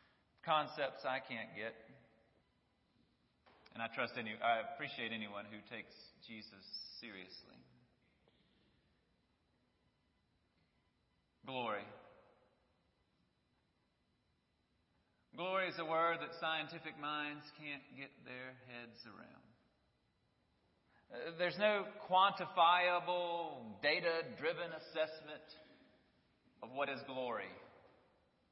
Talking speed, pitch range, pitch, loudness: 80 wpm, 110-170 Hz, 150 Hz, -39 LUFS